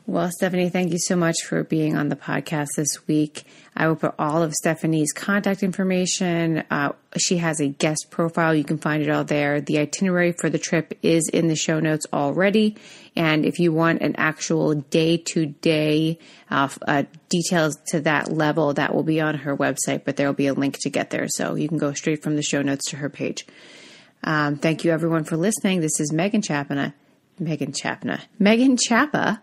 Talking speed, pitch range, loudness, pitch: 200 wpm, 150-175 Hz, -22 LUFS, 160 Hz